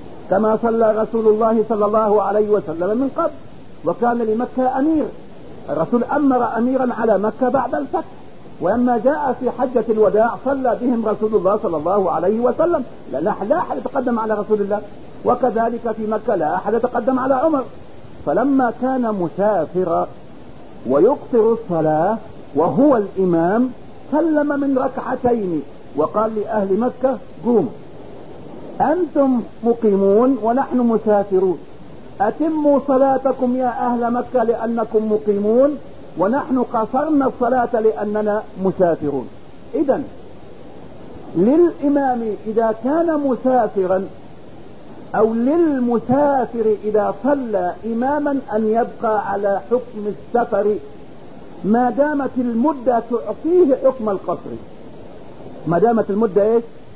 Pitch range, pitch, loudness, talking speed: 210-260 Hz, 235 Hz, -18 LUFS, 105 wpm